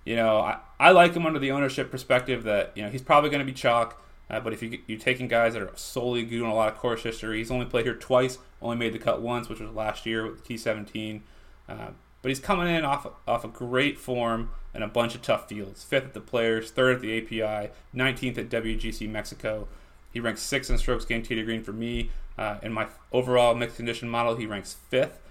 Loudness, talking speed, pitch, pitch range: -27 LUFS, 240 wpm, 115 Hz, 110-125 Hz